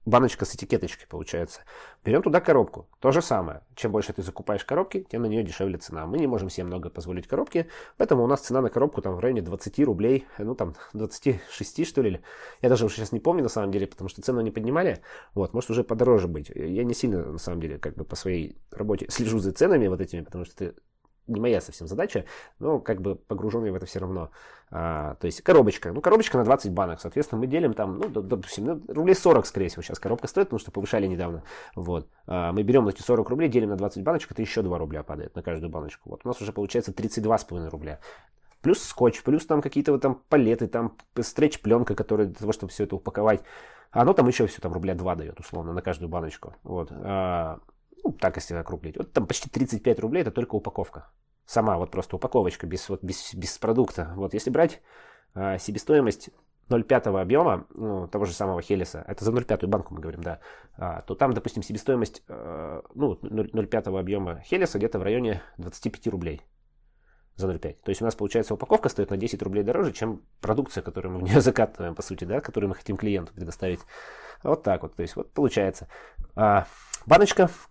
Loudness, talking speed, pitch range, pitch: -26 LUFS, 205 wpm, 90-115 Hz, 100 Hz